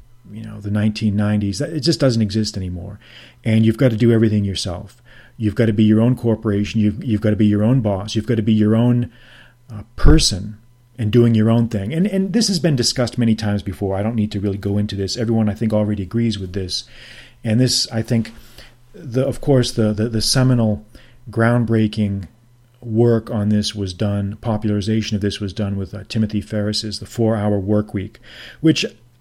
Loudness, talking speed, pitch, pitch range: -18 LUFS, 205 wpm, 110 Hz, 105-120 Hz